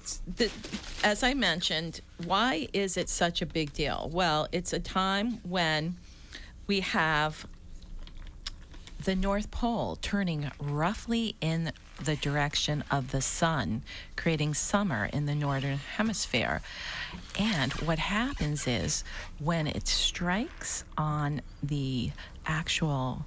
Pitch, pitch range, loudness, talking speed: 155 Hz, 135-190 Hz, -30 LUFS, 115 wpm